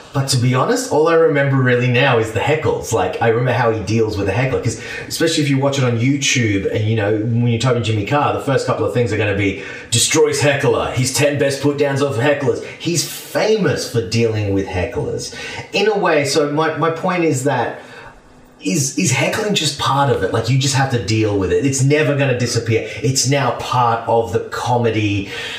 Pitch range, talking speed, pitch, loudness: 115-145 Hz, 230 wpm, 125 Hz, -17 LUFS